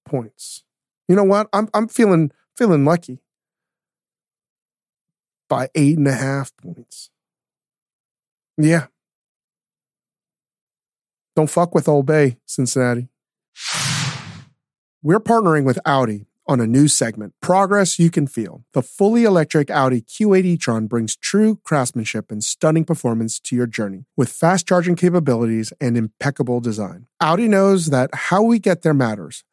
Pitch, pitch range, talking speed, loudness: 150 Hz, 125-180 Hz, 130 wpm, -18 LUFS